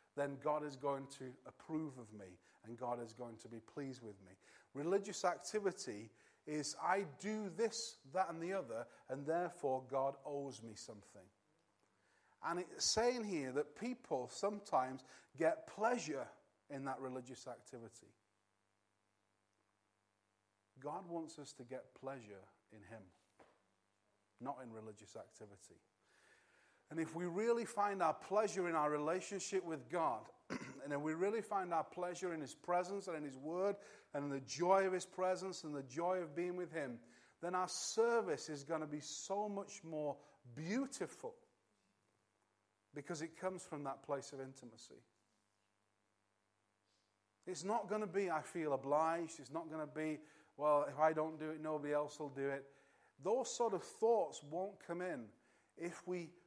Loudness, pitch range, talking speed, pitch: -42 LUFS, 120-180 Hz, 160 wpm, 150 Hz